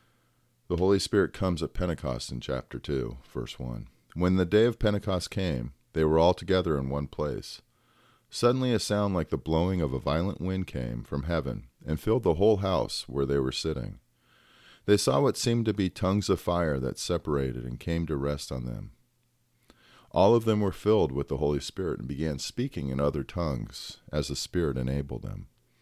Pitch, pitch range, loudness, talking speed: 85 Hz, 70-100 Hz, -29 LUFS, 195 wpm